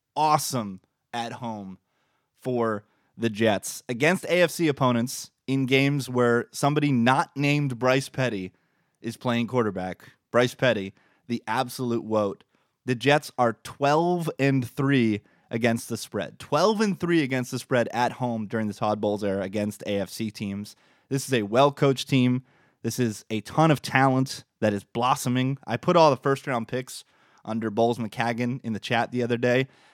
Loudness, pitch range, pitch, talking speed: -25 LUFS, 110-135 Hz, 125 Hz, 160 wpm